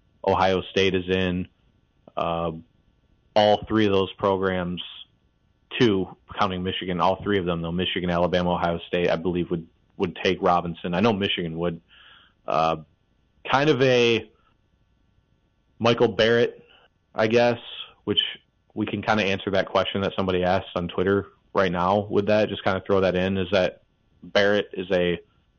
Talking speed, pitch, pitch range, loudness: 160 wpm, 95 Hz, 90-105 Hz, -24 LUFS